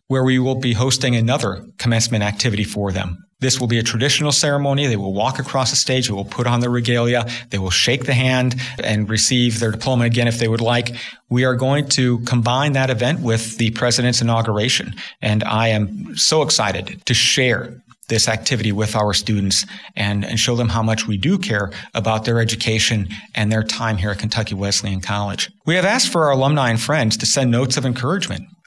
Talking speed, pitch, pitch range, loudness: 205 wpm, 120 Hz, 110-130 Hz, -18 LUFS